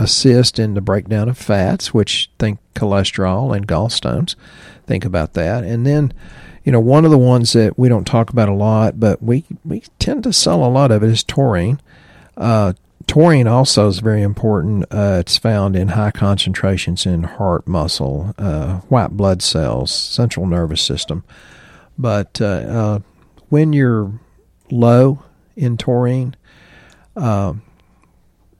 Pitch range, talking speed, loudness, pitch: 95-125 Hz, 150 wpm, -15 LUFS, 110 Hz